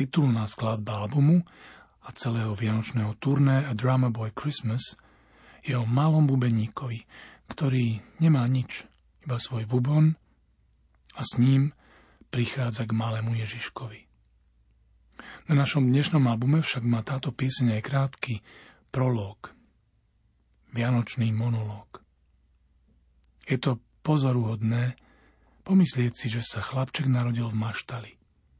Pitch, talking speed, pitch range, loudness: 120 Hz, 110 wpm, 110-135 Hz, -26 LUFS